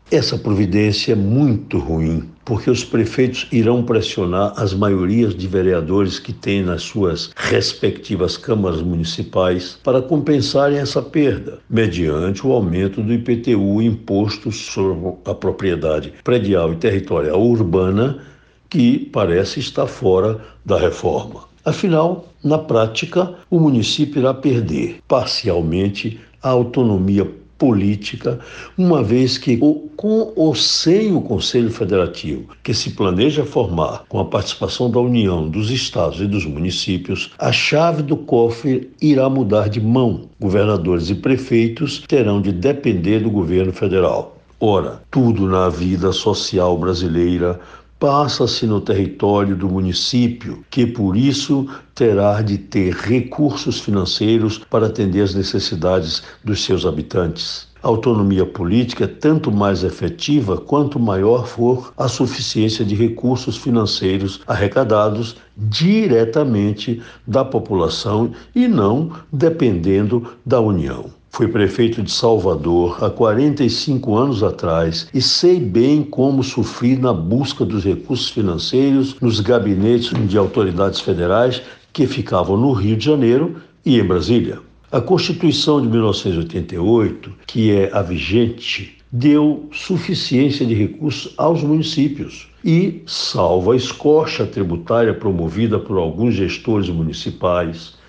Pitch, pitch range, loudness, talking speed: 115 Hz, 95-130 Hz, -17 LUFS, 125 wpm